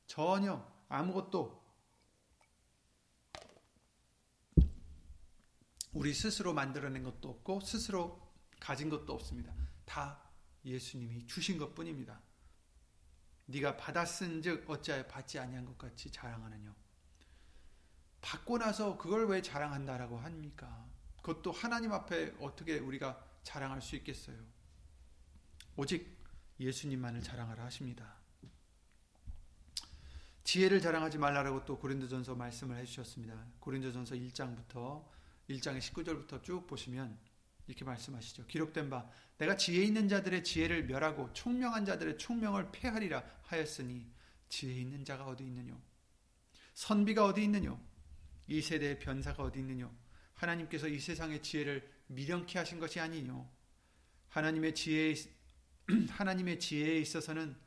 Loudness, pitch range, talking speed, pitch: -39 LUFS, 110-160 Hz, 280 characters per minute, 135 Hz